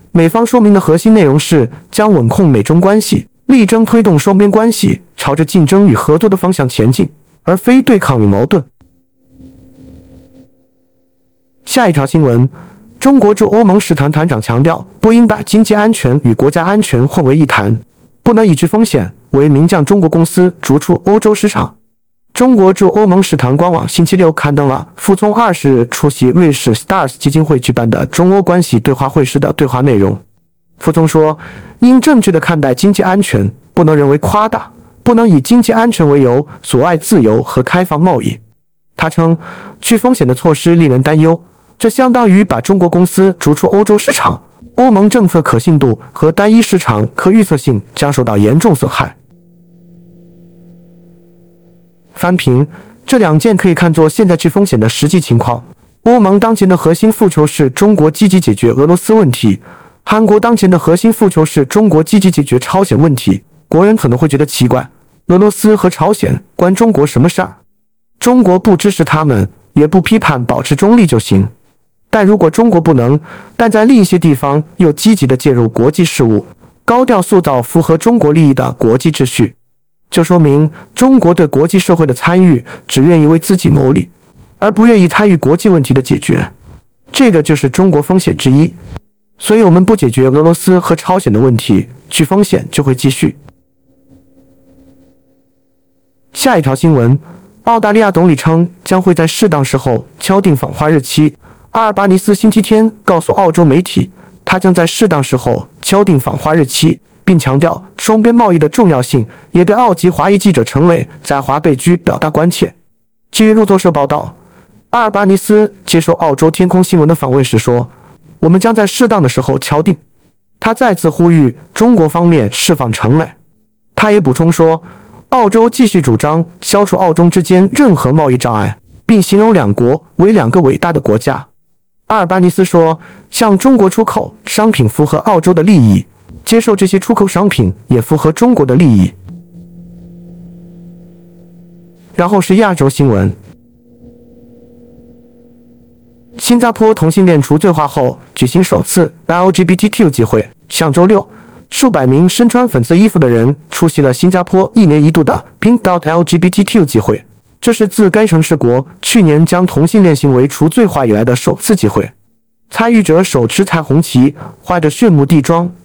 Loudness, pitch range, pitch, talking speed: -9 LUFS, 135-195 Hz, 170 Hz, 270 characters per minute